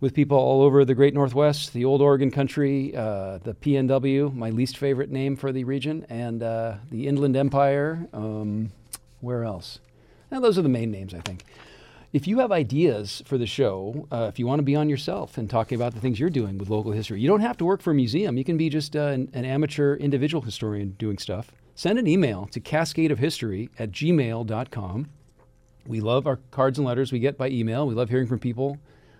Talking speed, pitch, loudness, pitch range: 215 wpm, 130 Hz, -24 LUFS, 115-145 Hz